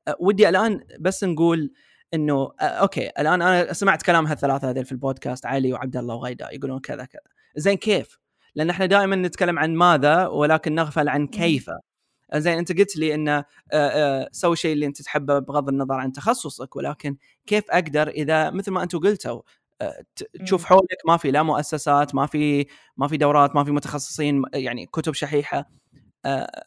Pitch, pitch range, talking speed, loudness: 150 Hz, 140-175 Hz, 175 wpm, -22 LUFS